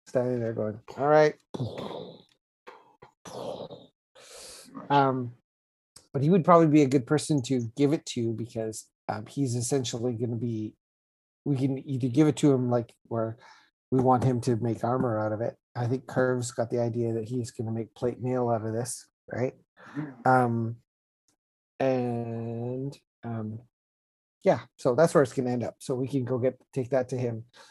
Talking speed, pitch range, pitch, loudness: 175 wpm, 115-135 Hz, 125 Hz, -28 LUFS